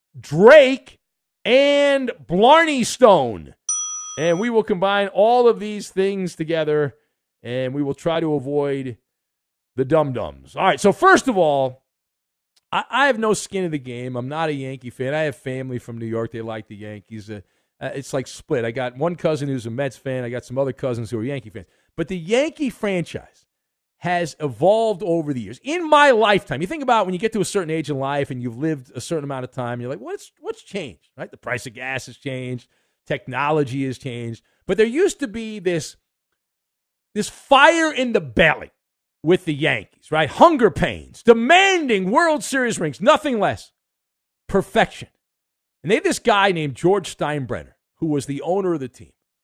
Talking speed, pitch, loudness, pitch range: 195 wpm, 160 Hz, -19 LUFS, 130-220 Hz